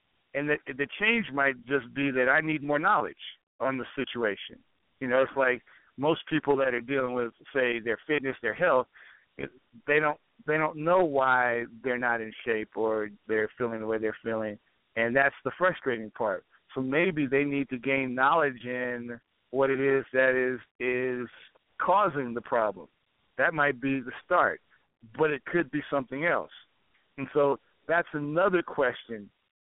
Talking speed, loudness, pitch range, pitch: 170 wpm, -28 LUFS, 120-145 Hz, 135 Hz